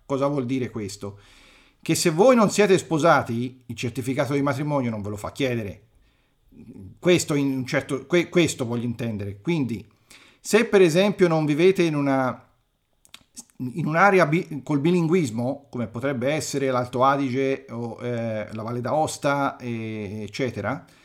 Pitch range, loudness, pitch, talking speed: 120-160 Hz, -23 LUFS, 135 Hz, 150 wpm